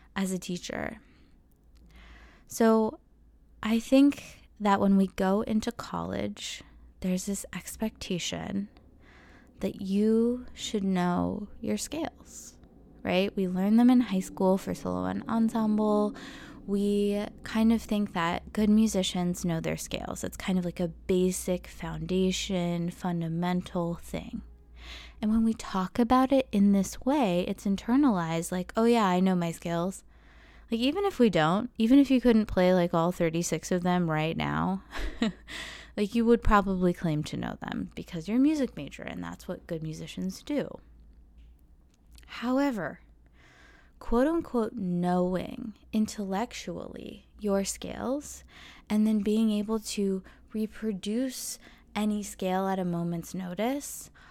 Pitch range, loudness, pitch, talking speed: 170-220 Hz, -28 LUFS, 190 Hz, 135 wpm